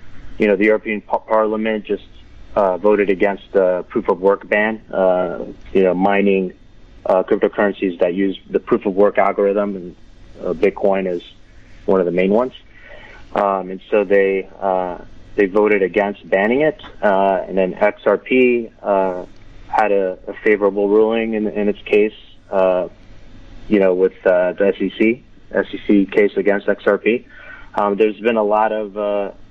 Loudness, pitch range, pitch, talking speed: -17 LUFS, 95-105 Hz, 100 Hz, 160 wpm